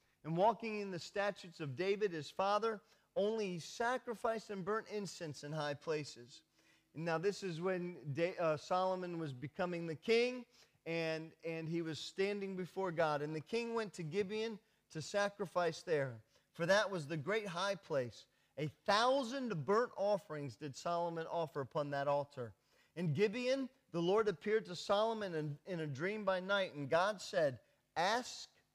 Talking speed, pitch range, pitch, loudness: 160 wpm, 155-205 Hz, 180 Hz, -39 LUFS